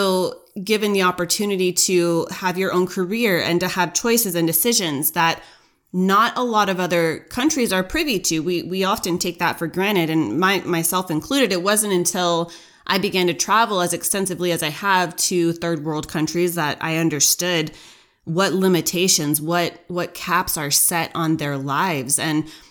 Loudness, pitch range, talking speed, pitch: -19 LUFS, 165-190 Hz, 170 wpm, 175 Hz